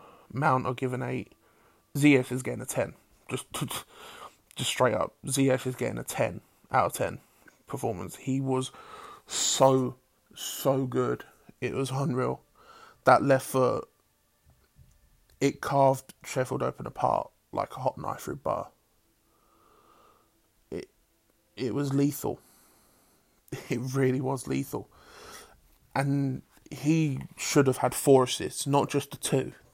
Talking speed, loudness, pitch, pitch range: 125 wpm, -28 LUFS, 135 Hz, 130-140 Hz